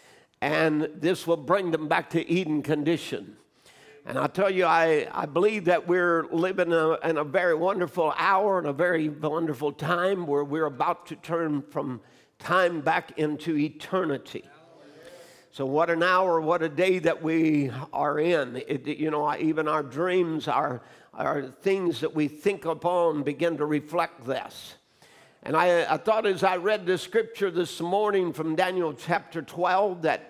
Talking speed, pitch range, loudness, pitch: 170 wpm, 155-180 Hz, -26 LUFS, 165 Hz